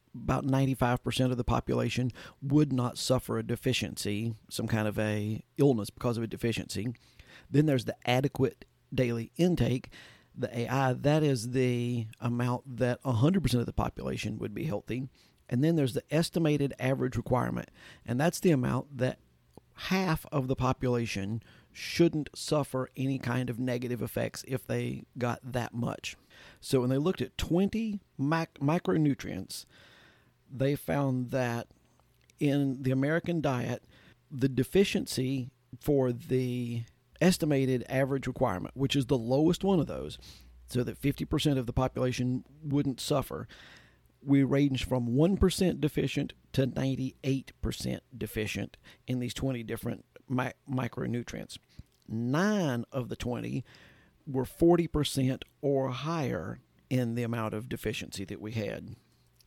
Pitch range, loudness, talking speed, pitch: 120-140 Hz, -31 LUFS, 135 wpm, 130 Hz